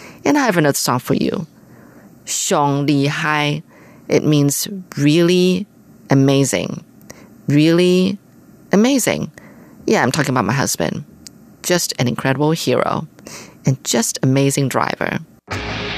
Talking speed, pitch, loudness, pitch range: 115 wpm, 145 Hz, -17 LUFS, 135-175 Hz